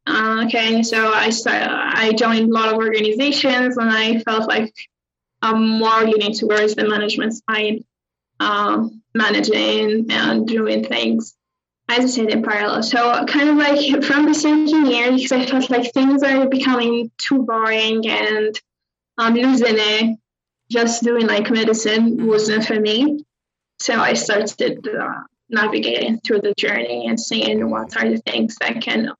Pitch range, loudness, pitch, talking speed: 215-240 Hz, -17 LUFS, 225 Hz, 155 wpm